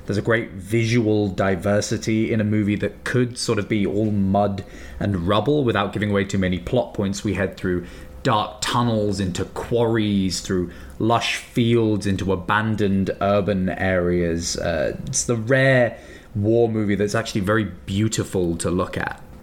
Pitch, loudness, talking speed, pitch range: 105 Hz, -21 LUFS, 160 wpm, 95-115 Hz